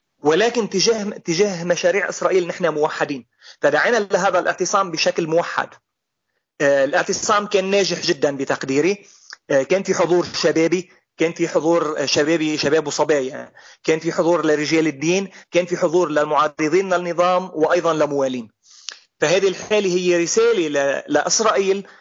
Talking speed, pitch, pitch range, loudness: 125 wpm, 175 Hz, 155-190 Hz, -19 LUFS